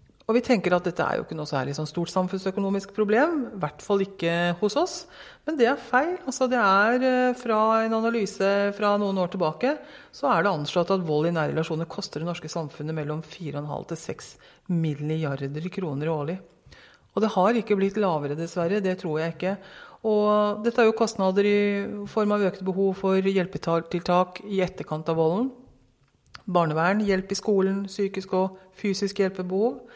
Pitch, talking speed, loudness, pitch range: 190 Hz, 180 wpm, -25 LUFS, 165-210 Hz